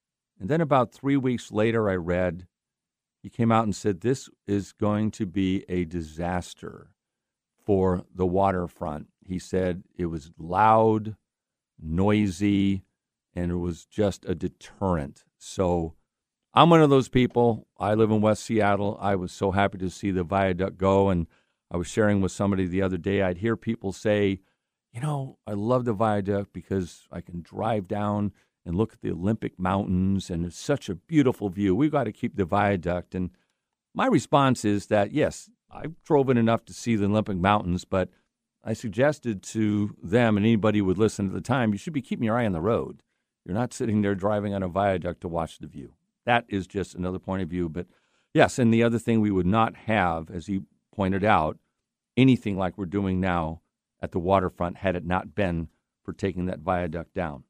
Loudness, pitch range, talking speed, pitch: -25 LUFS, 90-110 Hz, 190 wpm, 100 Hz